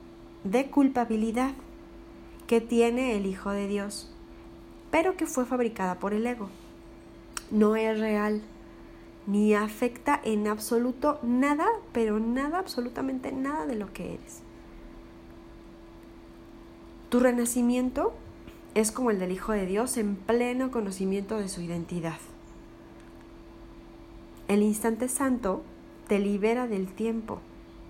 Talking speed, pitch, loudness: 115 wpm, 210 Hz, -28 LUFS